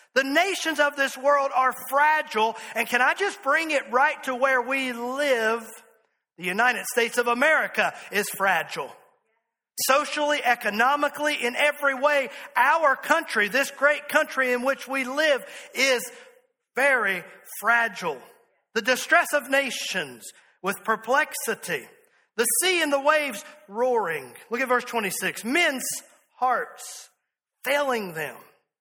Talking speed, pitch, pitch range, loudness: 130 wpm, 265 Hz, 235-295 Hz, -23 LUFS